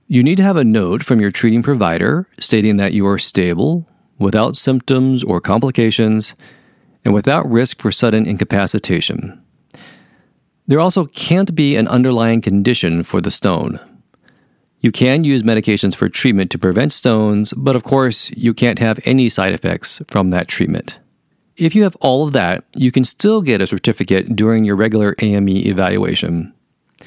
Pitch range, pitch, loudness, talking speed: 105-135 Hz, 115 Hz, -14 LUFS, 160 wpm